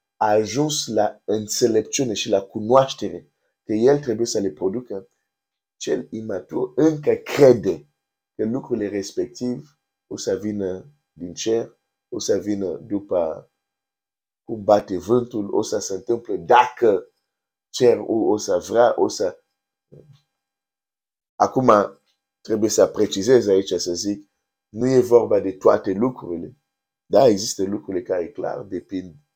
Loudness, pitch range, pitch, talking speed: -21 LUFS, 100-135 Hz, 110 Hz, 140 wpm